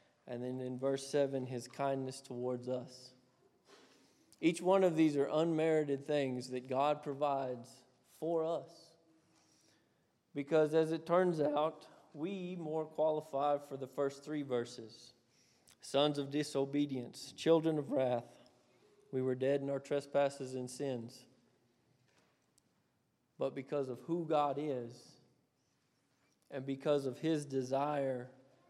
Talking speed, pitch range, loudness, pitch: 125 wpm, 130-155 Hz, -36 LUFS, 140 Hz